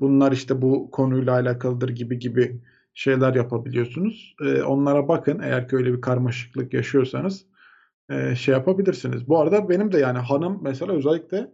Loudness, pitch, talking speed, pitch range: -22 LUFS, 130 Hz, 145 wpm, 125-160 Hz